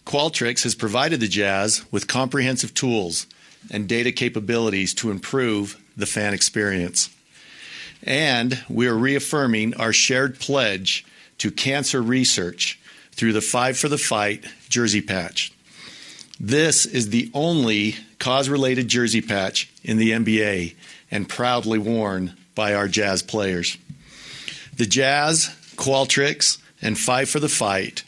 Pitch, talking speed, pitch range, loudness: 115 Hz, 130 wpm, 105-130 Hz, -21 LUFS